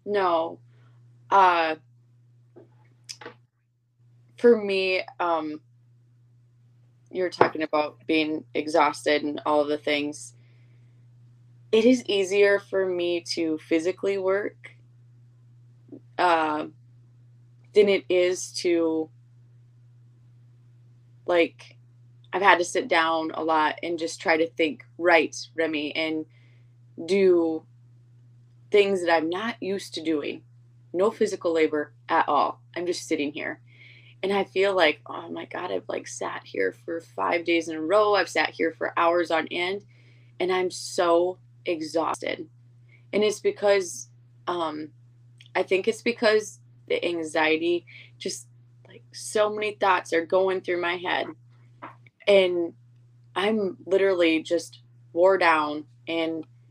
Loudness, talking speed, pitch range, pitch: -25 LUFS, 125 wpm, 120-175 Hz, 150 Hz